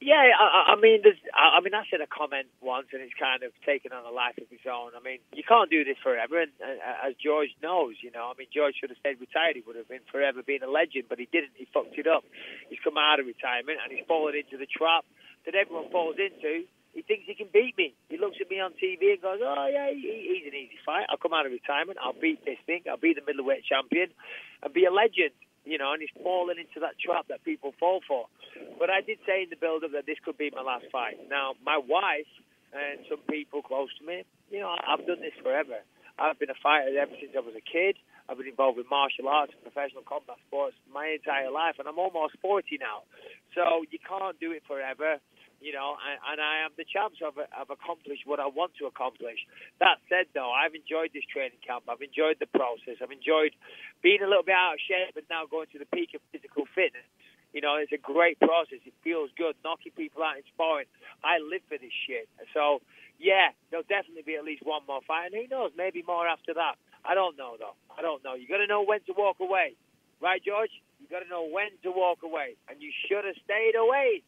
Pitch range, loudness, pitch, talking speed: 145-215 Hz, -28 LUFS, 165 Hz, 245 wpm